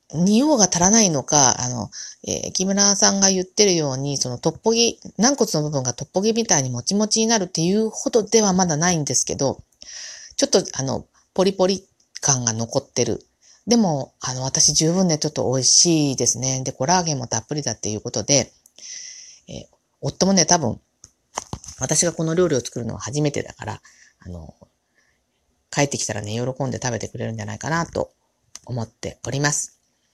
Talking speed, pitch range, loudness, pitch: 360 characters per minute, 125-190 Hz, -19 LUFS, 150 Hz